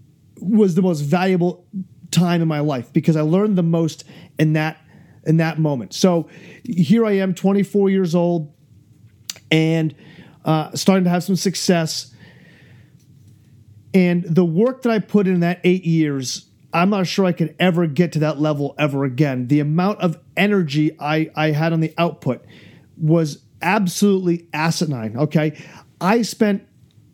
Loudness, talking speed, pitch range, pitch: -19 LUFS, 155 wpm, 150-185 Hz, 165 Hz